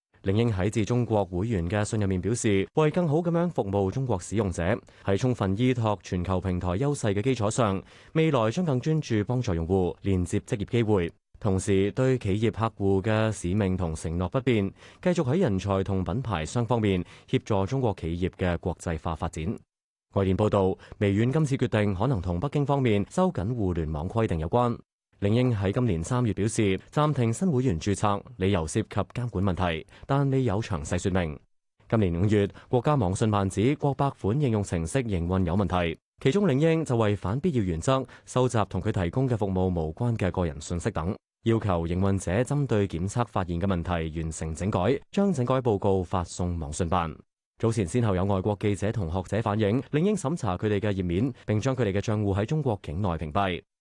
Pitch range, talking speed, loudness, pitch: 95-125 Hz, 300 characters per minute, -27 LUFS, 100 Hz